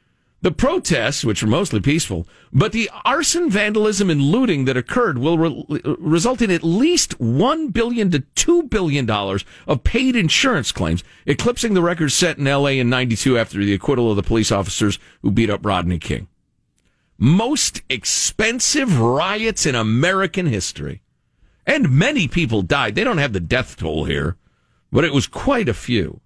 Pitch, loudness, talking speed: 140 Hz, -18 LUFS, 170 wpm